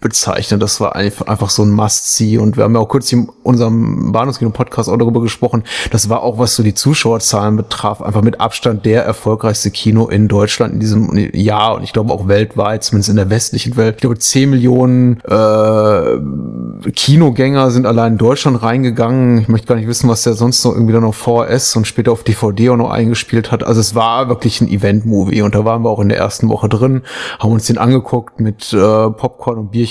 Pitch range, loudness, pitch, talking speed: 105-120 Hz, -12 LUFS, 115 Hz, 215 wpm